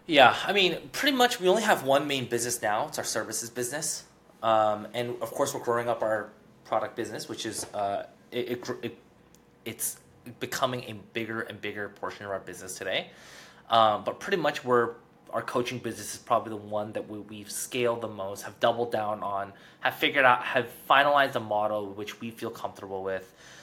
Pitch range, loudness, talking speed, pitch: 105-125 Hz, -28 LUFS, 195 wpm, 115 Hz